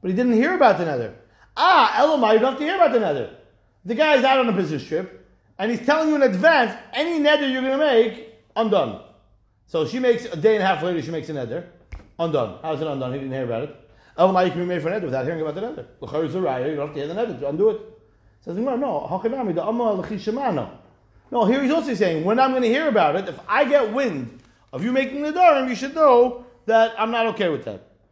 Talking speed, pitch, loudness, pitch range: 250 wpm, 225 Hz, -21 LUFS, 165-265 Hz